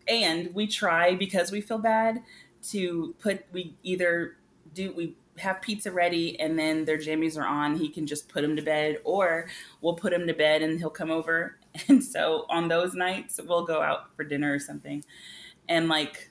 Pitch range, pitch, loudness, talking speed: 155-185 Hz, 170 Hz, -27 LUFS, 195 wpm